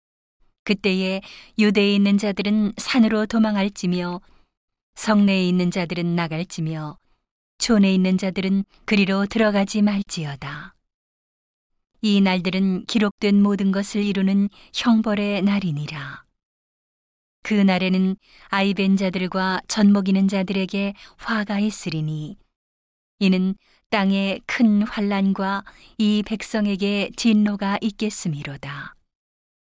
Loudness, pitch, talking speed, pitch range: -21 LUFS, 195 Hz, 235 characters per minute, 185-210 Hz